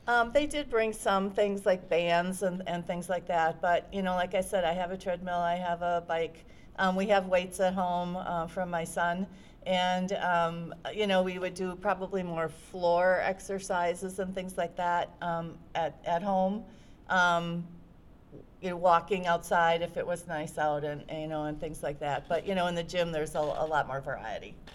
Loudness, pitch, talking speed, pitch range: -31 LUFS, 175 Hz, 210 wpm, 170-190 Hz